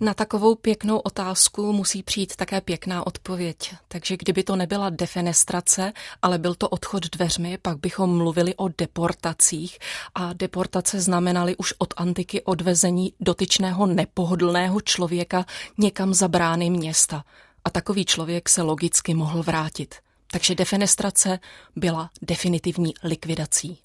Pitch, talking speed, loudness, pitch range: 180 Hz, 125 wpm, -22 LUFS, 175-190 Hz